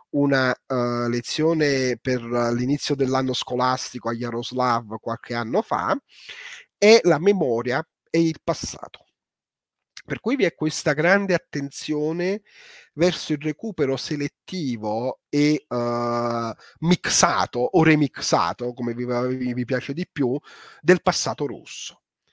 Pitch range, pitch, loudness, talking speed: 120-165 Hz, 140 Hz, -23 LUFS, 120 wpm